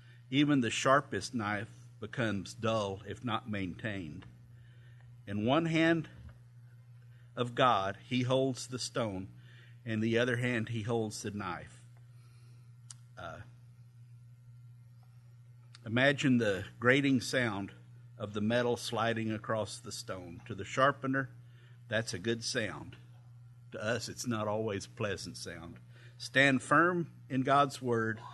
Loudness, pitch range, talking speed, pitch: -32 LUFS, 110-125 Hz, 125 wpm, 120 Hz